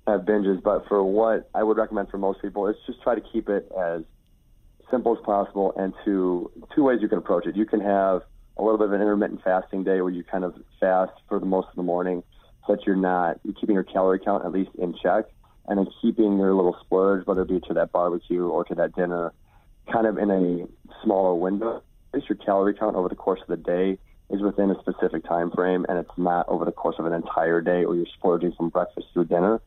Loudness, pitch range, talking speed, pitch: -24 LUFS, 90-105 Hz, 240 wpm, 95 Hz